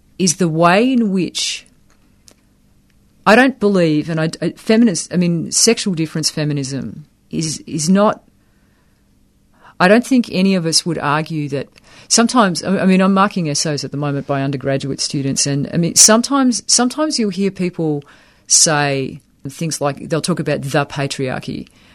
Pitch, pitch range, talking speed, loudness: 165 Hz, 145-200 Hz, 155 wpm, -15 LUFS